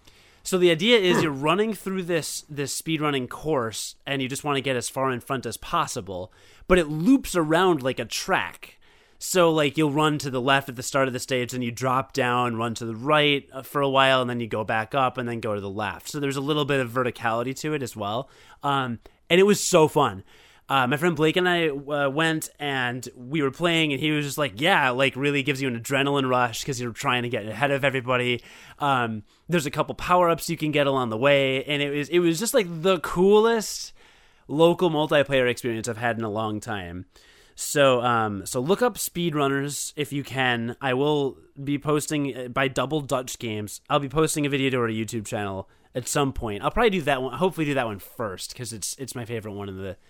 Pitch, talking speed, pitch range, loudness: 135 Hz, 230 wpm, 120-155 Hz, -24 LUFS